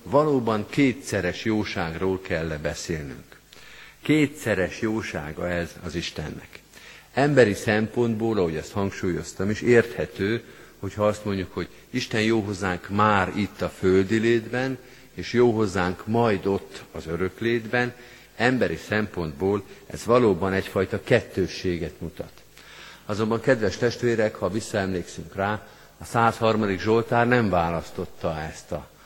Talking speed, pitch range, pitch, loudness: 115 wpm, 90-115 Hz, 105 Hz, -24 LUFS